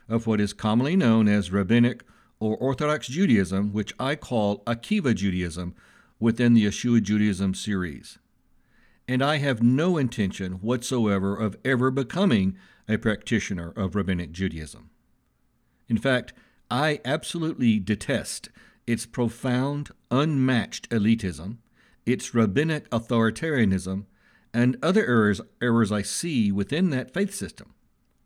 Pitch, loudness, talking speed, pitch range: 115 Hz, -25 LUFS, 120 wpm, 105-135 Hz